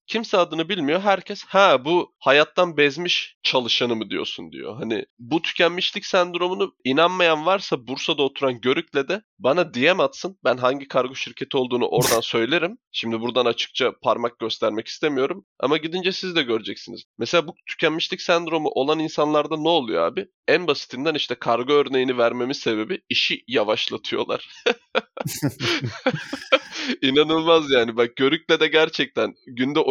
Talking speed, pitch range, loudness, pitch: 135 wpm, 130-175 Hz, -21 LUFS, 155 Hz